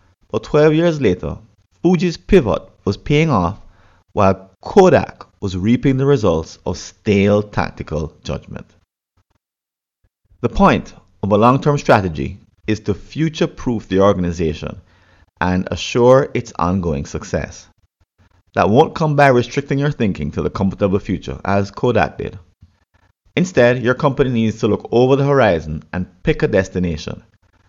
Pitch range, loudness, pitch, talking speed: 90-125 Hz, -17 LUFS, 100 Hz, 140 wpm